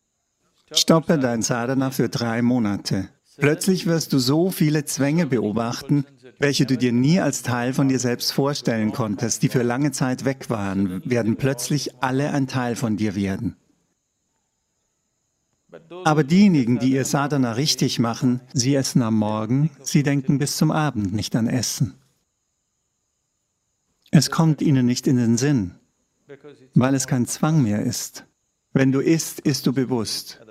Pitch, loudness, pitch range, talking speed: 135 Hz, -21 LUFS, 120-145 Hz, 150 wpm